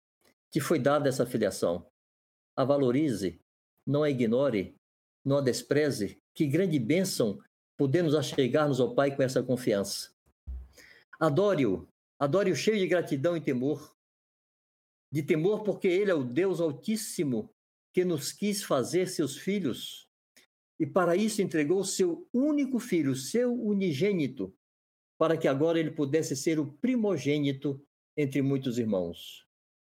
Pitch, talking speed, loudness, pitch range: 150 Hz, 135 wpm, -29 LUFS, 135-185 Hz